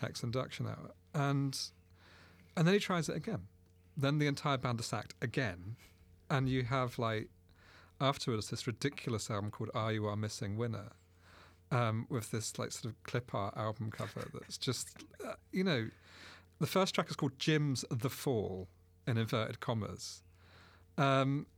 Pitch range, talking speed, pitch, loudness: 90-135 Hz, 160 wpm, 115 Hz, -37 LUFS